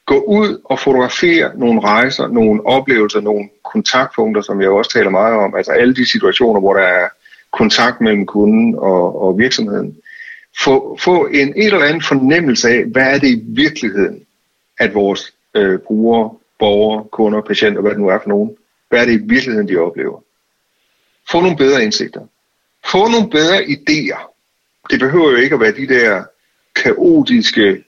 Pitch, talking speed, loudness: 175 Hz, 170 wpm, -13 LUFS